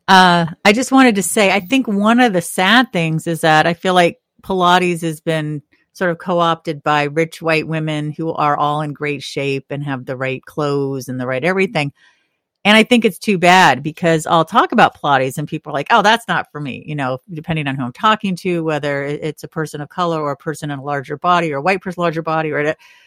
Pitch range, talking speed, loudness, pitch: 145-185 Hz, 240 wpm, -16 LUFS, 160 Hz